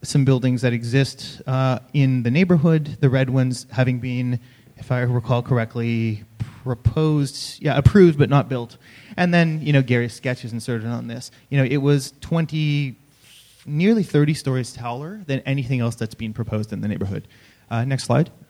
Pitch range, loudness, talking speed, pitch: 120-145 Hz, -21 LUFS, 170 wpm, 130 Hz